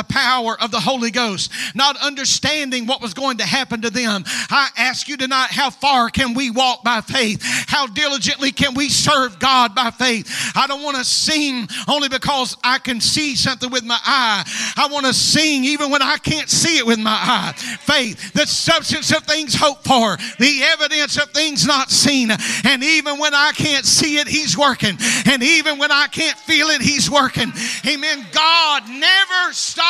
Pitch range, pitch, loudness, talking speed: 240-290 Hz, 265 Hz, -15 LUFS, 195 wpm